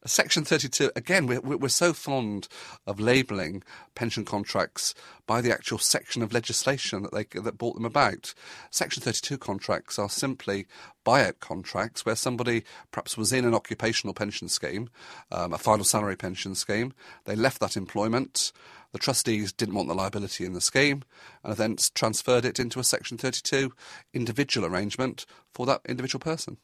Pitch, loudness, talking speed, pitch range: 115 Hz, -27 LUFS, 160 wpm, 105-130 Hz